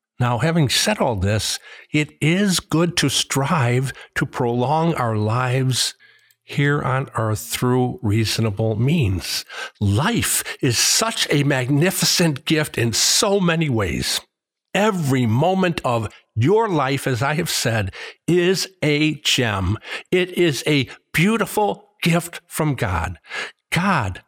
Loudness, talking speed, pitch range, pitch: -20 LUFS, 125 wpm, 115-170 Hz, 145 Hz